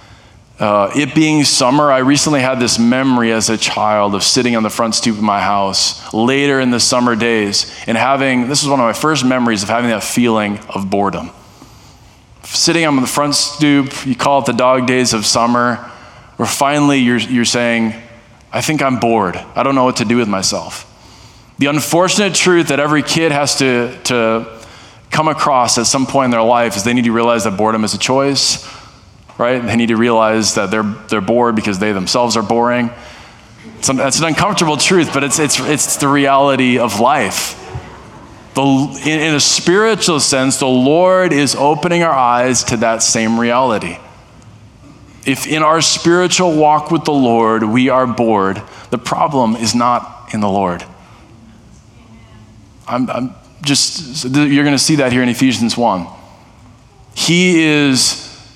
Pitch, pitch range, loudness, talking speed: 120 Hz, 115-140 Hz, -13 LUFS, 175 wpm